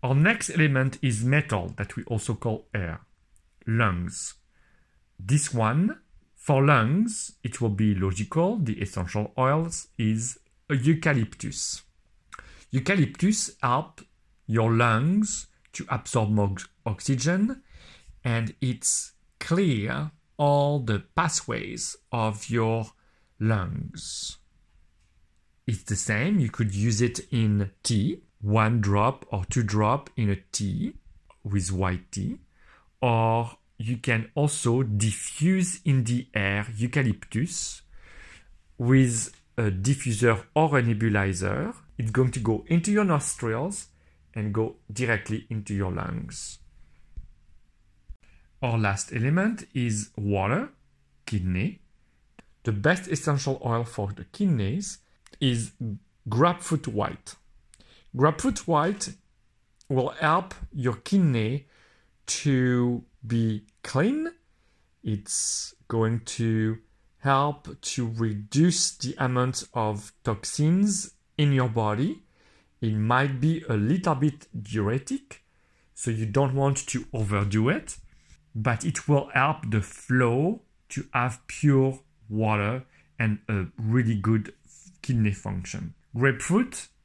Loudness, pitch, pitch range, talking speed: -26 LUFS, 115 Hz, 105-145 Hz, 110 wpm